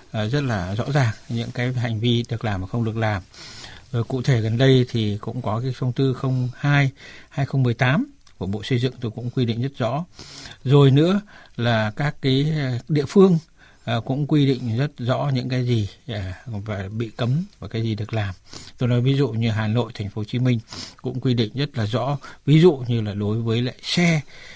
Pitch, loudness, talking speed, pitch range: 125 Hz, -22 LUFS, 210 wpm, 110-135 Hz